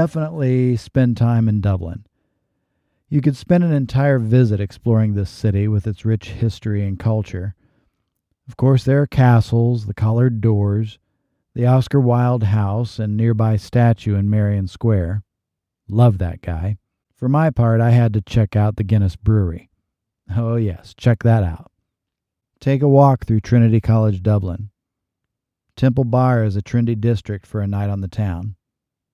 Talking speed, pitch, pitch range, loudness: 155 wpm, 110 Hz, 100-120 Hz, -18 LUFS